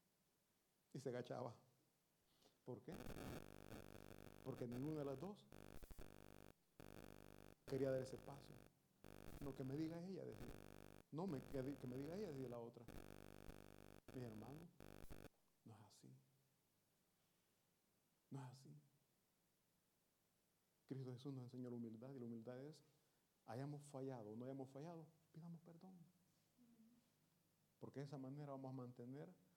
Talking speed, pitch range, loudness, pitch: 125 wpm, 125-160 Hz, -55 LUFS, 135 Hz